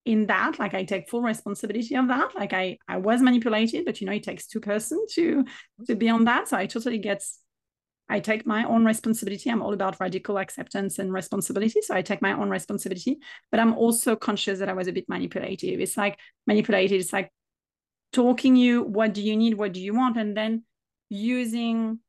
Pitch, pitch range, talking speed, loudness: 215 Hz, 200-235 Hz, 205 wpm, -25 LUFS